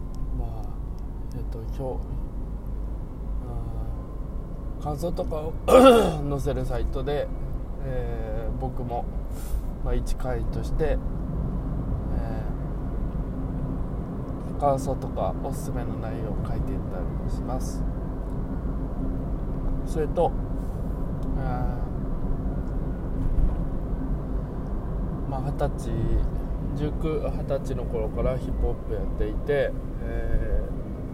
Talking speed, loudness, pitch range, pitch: 165 characters per minute, -29 LUFS, 120-150 Hz, 130 Hz